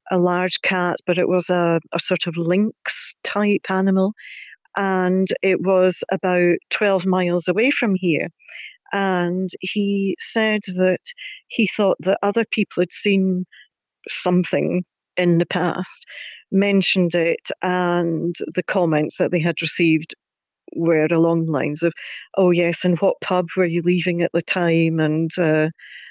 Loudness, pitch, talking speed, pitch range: -20 LUFS, 180 Hz, 145 wpm, 170-190 Hz